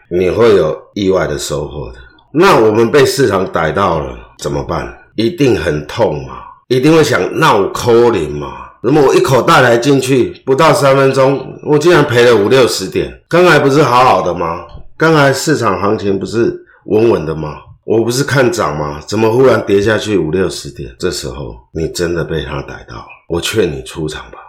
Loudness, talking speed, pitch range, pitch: -12 LUFS, 270 characters per minute, 95-140 Hz, 120 Hz